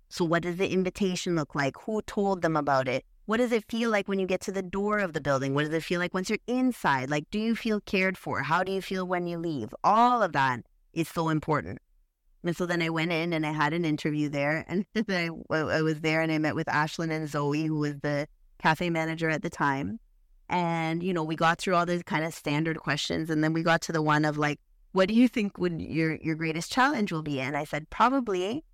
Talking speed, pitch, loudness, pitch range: 250 wpm, 165 Hz, -28 LUFS, 150-190 Hz